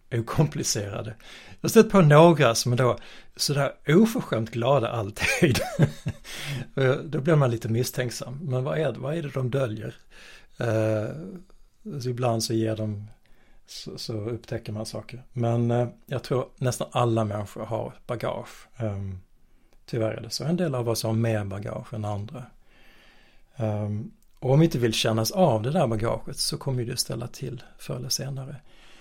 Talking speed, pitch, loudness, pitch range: 165 wpm, 120 Hz, -25 LUFS, 110-140 Hz